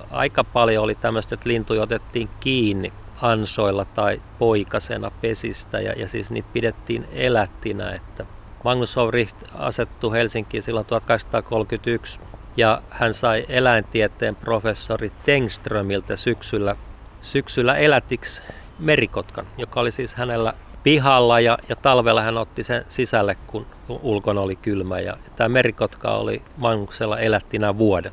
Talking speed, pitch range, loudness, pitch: 125 wpm, 105-115 Hz, -21 LUFS, 110 Hz